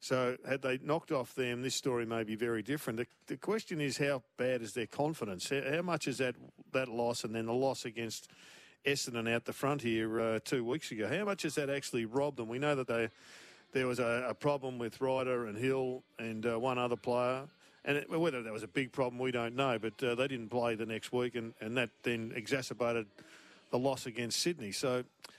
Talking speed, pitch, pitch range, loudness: 225 wpm, 125 Hz, 115-135 Hz, -36 LUFS